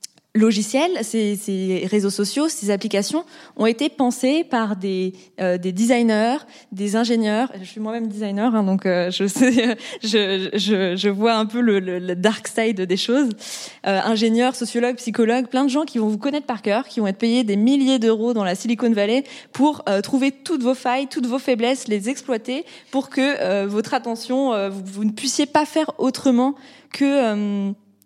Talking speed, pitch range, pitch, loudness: 190 wpm, 205-265 Hz, 230 Hz, -20 LUFS